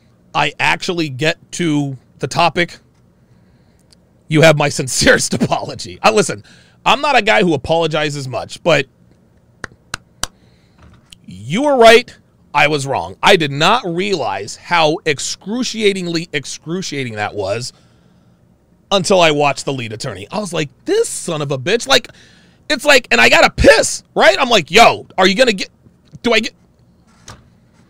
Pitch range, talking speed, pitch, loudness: 130-185 Hz, 145 wpm, 155 Hz, -14 LUFS